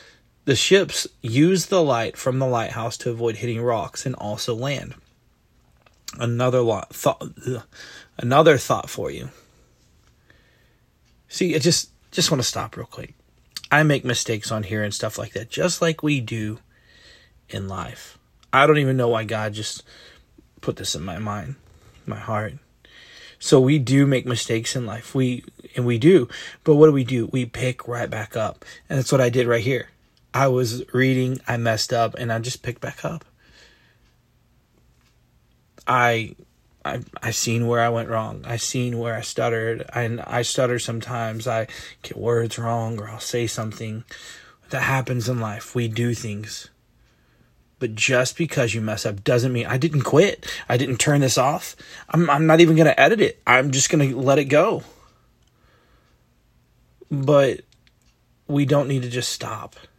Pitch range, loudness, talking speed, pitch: 115-135 Hz, -21 LUFS, 170 wpm, 120 Hz